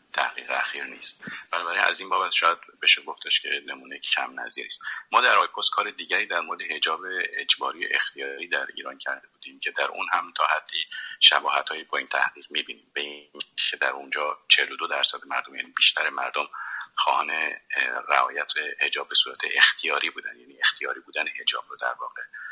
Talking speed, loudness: 180 wpm, -24 LUFS